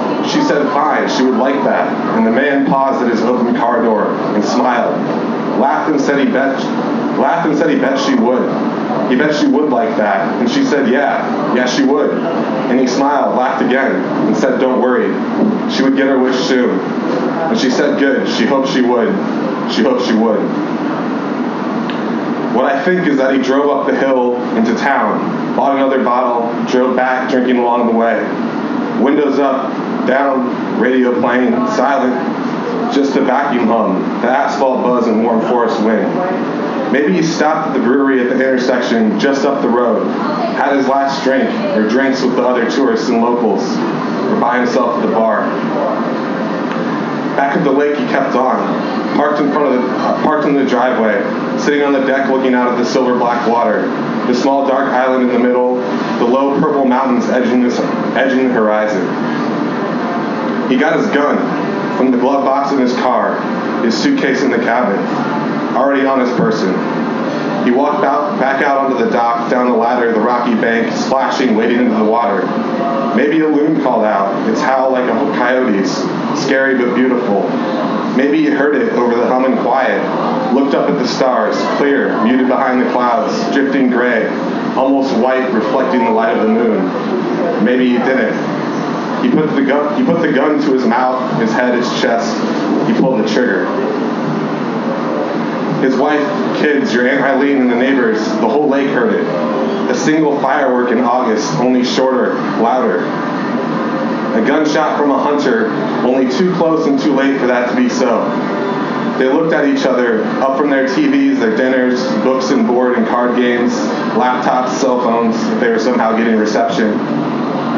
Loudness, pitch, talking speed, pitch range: -13 LUFS, 130 Hz, 180 wpm, 125-140 Hz